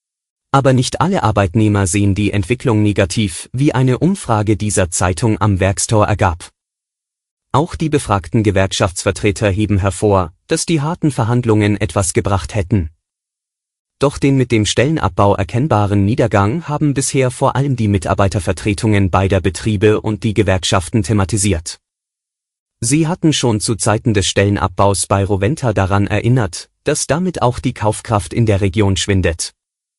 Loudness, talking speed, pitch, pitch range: -15 LUFS, 135 wpm, 105 Hz, 100-120 Hz